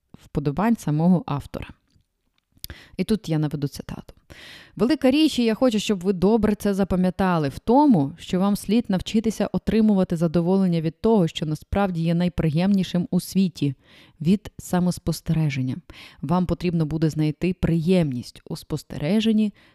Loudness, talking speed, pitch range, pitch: -22 LUFS, 130 wpm, 160-205 Hz, 180 Hz